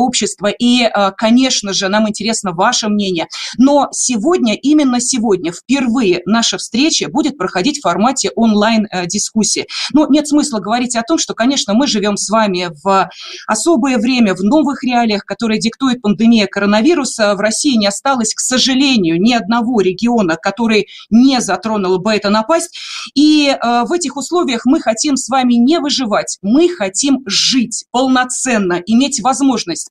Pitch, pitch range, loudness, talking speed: 230 Hz, 205-270 Hz, -13 LUFS, 145 wpm